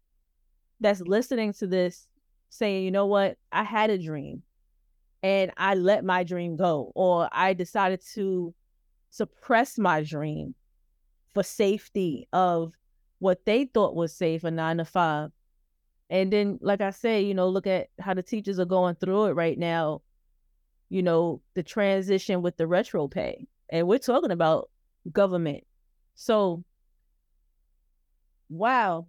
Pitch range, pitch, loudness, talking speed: 145-195 Hz, 180 Hz, -26 LUFS, 145 wpm